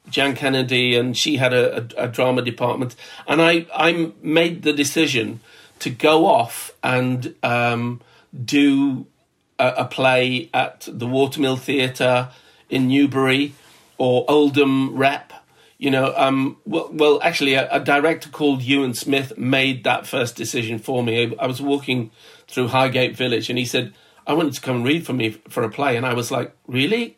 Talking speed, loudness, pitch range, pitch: 170 wpm, -19 LUFS, 125-145 Hz, 130 Hz